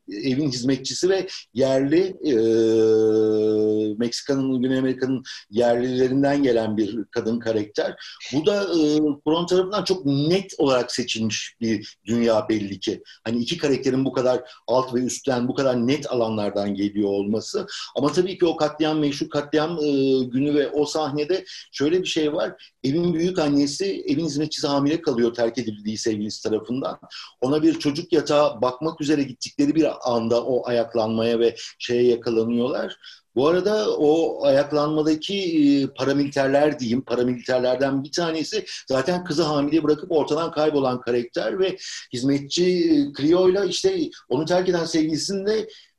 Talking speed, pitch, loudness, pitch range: 140 wpm, 140 Hz, -22 LUFS, 120-160 Hz